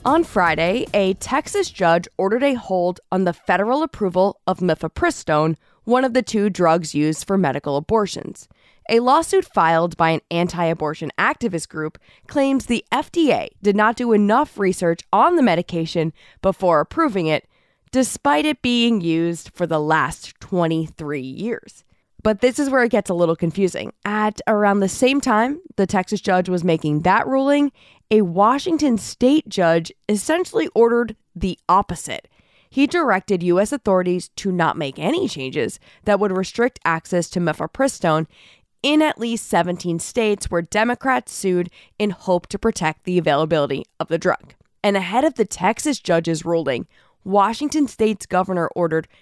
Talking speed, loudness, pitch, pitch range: 155 wpm, -20 LUFS, 195 Hz, 170-240 Hz